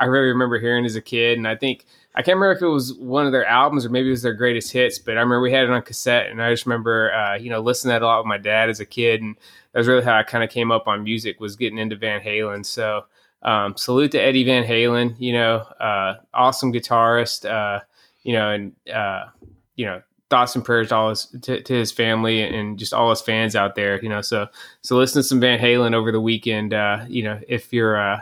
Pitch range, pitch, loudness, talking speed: 110-125 Hz, 115 Hz, -20 LUFS, 265 wpm